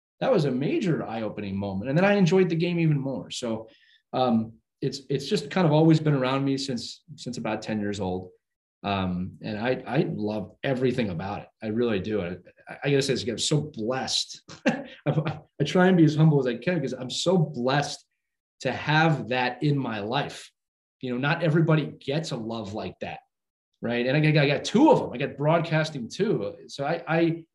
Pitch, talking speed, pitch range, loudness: 135 Hz, 205 wpm, 115-155 Hz, -26 LUFS